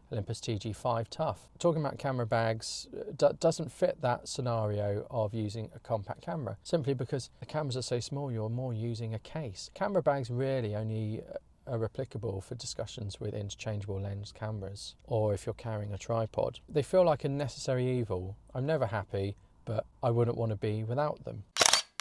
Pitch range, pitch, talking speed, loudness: 110-135 Hz, 115 Hz, 175 wpm, -33 LUFS